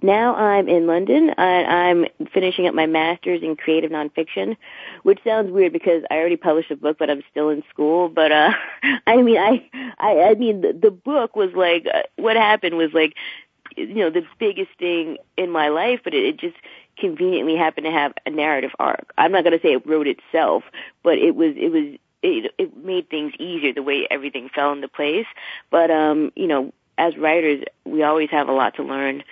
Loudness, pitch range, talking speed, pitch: -19 LUFS, 155-245 Hz, 205 wpm, 175 Hz